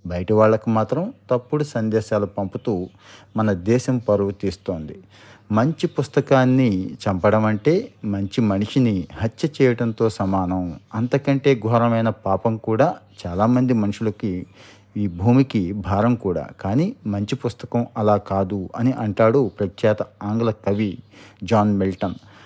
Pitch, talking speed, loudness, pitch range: 110 Hz, 110 wpm, -21 LUFS, 100-120 Hz